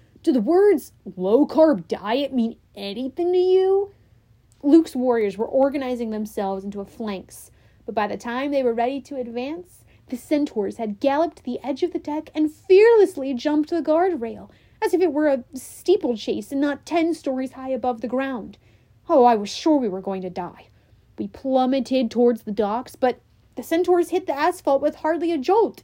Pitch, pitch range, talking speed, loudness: 265 Hz, 225-315 Hz, 185 wpm, -22 LUFS